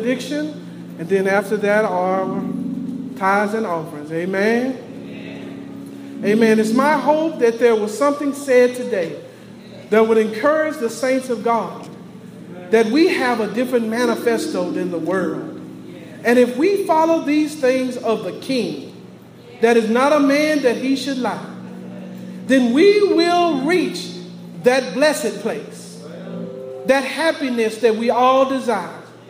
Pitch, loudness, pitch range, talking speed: 235 Hz, -18 LUFS, 195-265 Hz, 135 wpm